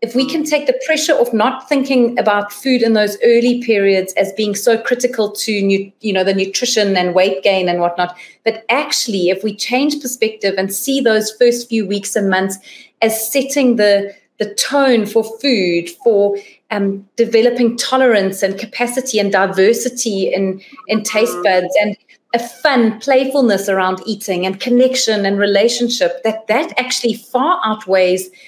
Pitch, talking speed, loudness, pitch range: 220 Hz, 165 wpm, -15 LUFS, 195-245 Hz